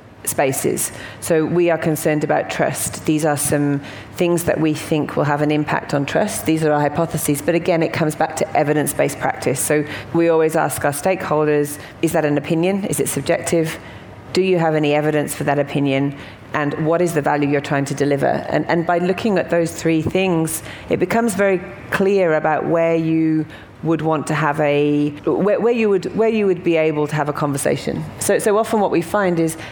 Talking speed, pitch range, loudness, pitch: 205 wpm, 145-170 Hz, -18 LUFS, 160 Hz